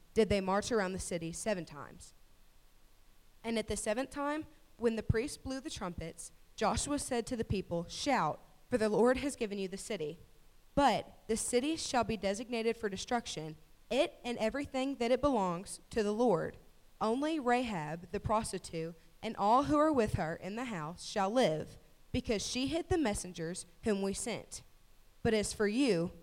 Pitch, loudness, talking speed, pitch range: 220 Hz, -34 LUFS, 175 wpm, 190-250 Hz